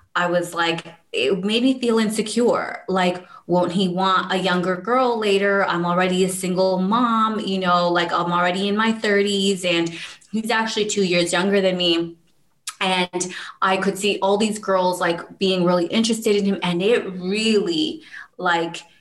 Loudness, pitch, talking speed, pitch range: -20 LUFS, 190 Hz, 170 wpm, 175-210 Hz